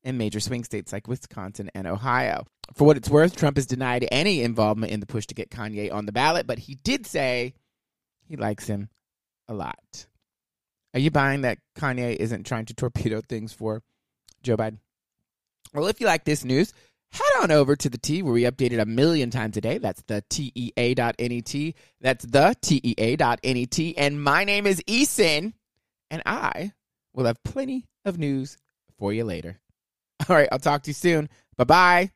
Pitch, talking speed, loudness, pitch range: 125 Hz, 200 wpm, -24 LUFS, 110-150 Hz